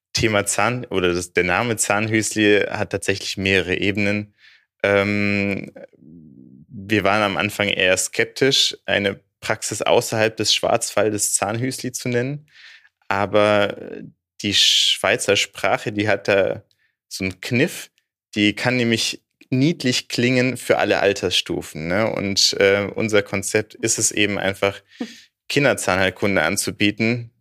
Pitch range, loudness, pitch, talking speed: 100-115 Hz, -19 LUFS, 105 Hz, 120 wpm